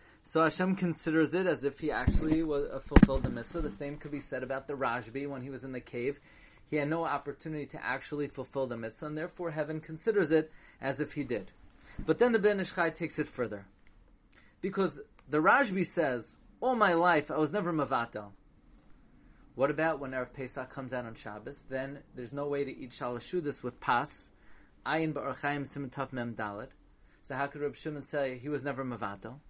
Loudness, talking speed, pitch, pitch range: -33 LUFS, 185 wpm, 145 Hz, 130-160 Hz